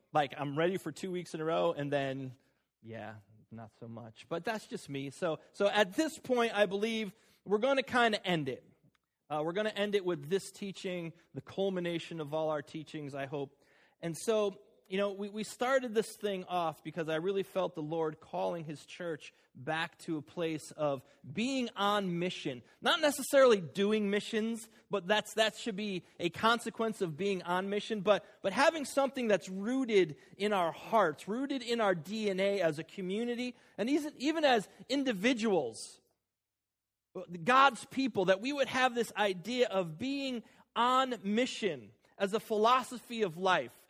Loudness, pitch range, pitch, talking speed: -33 LUFS, 160-225 Hz, 195 Hz, 185 wpm